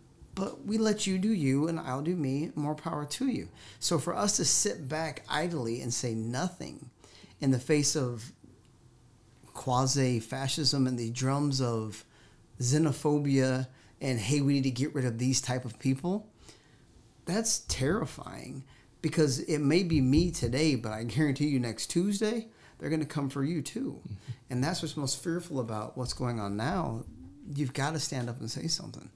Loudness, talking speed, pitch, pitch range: -30 LUFS, 175 wpm, 135 Hz, 125-155 Hz